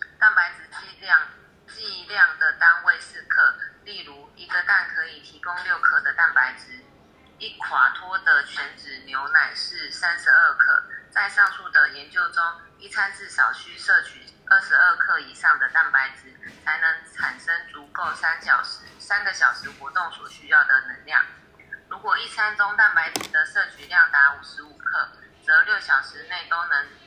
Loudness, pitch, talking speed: -20 LUFS, 225 Hz, 240 characters per minute